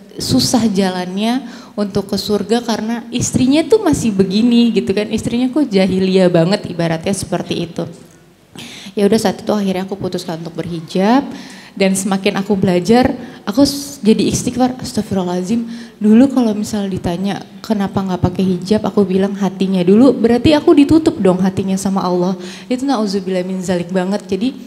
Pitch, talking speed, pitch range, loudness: 205 Hz, 145 wpm, 190-235 Hz, -15 LUFS